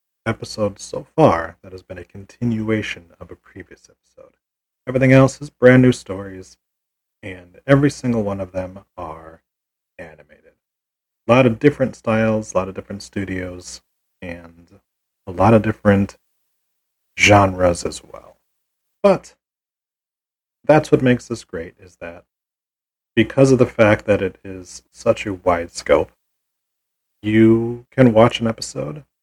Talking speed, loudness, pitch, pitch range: 140 wpm, -17 LUFS, 100 Hz, 95-115 Hz